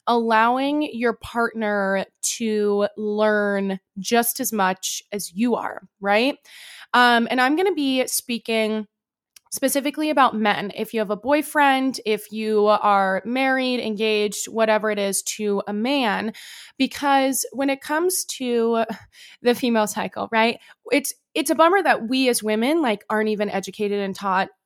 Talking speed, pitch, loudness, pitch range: 150 wpm, 225 Hz, -21 LUFS, 210-260 Hz